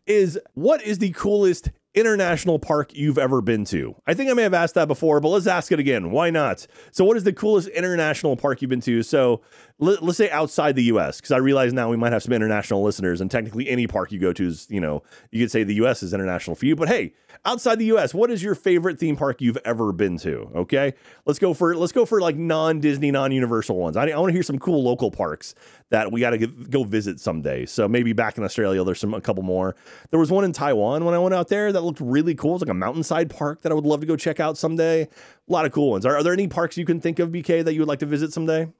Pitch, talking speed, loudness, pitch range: 150 Hz, 270 wpm, -22 LUFS, 120-175 Hz